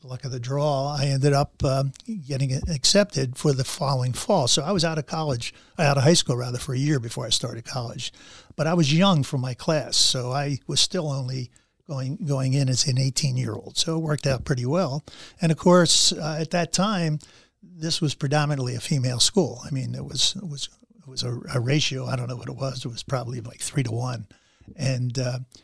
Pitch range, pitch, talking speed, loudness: 130-155 Hz, 140 Hz, 225 wpm, -24 LUFS